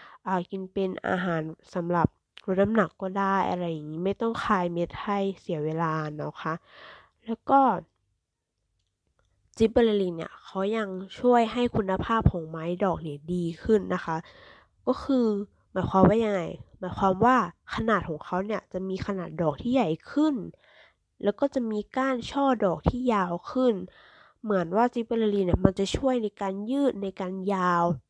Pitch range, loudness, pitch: 170-225 Hz, -27 LUFS, 195 Hz